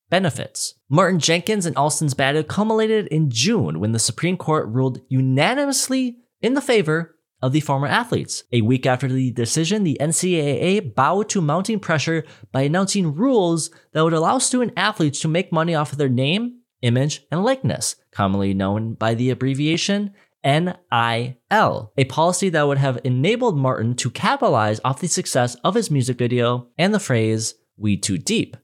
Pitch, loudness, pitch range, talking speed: 155 Hz, -20 LUFS, 130-185 Hz, 165 wpm